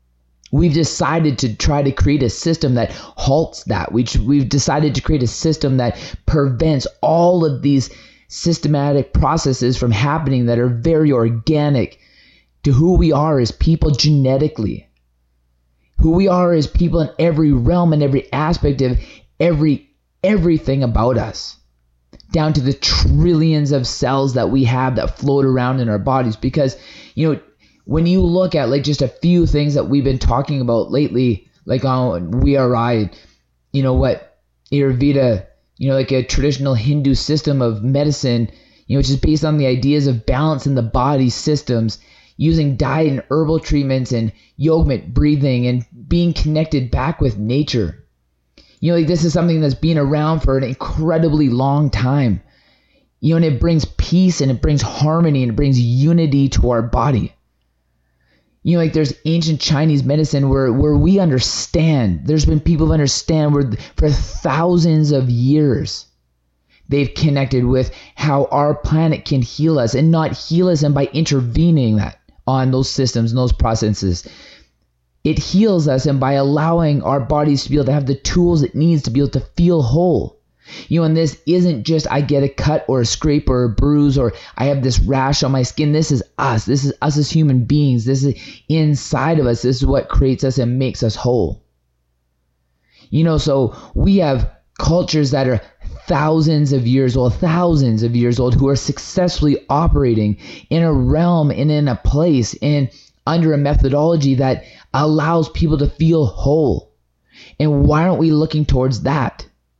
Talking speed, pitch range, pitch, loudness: 175 wpm, 125-155 Hz, 140 Hz, -16 LUFS